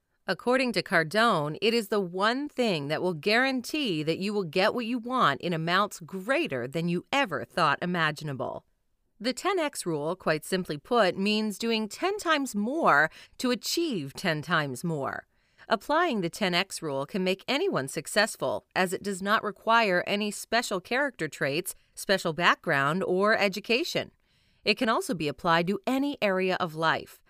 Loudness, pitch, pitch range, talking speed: -27 LUFS, 200 Hz, 170-235 Hz, 160 wpm